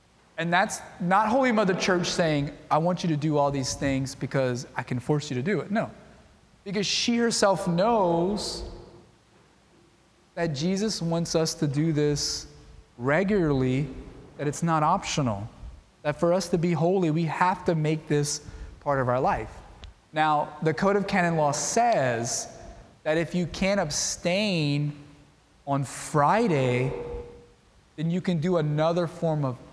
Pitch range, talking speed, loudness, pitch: 140-180 Hz, 155 wpm, -26 LUFS, 155 Hz